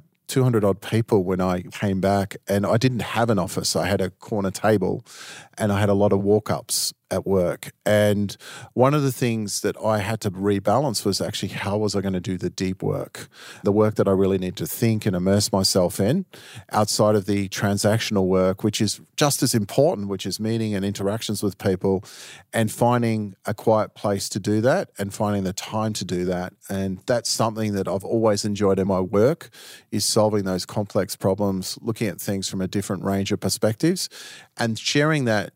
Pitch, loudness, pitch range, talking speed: 105 Hz, -23 LUFS, 95-110 Hz, 200 wpm